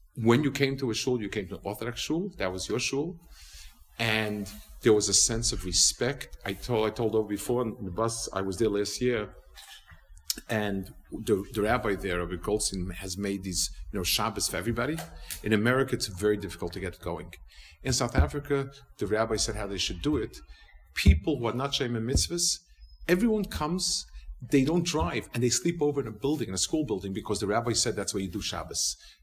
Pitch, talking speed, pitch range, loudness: 105 Hz, 210 wpm, 95-125 Hz, -28 LUFS